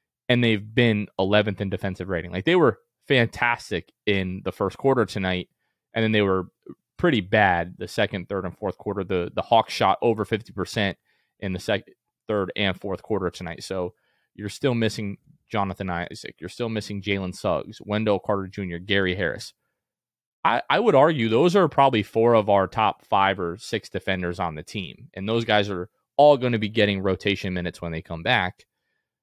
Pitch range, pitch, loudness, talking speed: 95-110 Hz, 100 Hz, -24 LUFS, 190 wpm